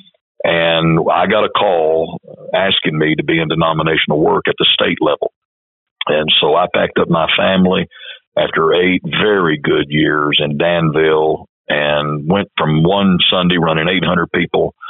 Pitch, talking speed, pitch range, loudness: 80 Hz, 155 wpm, 80-85 Hz, -14 LUFS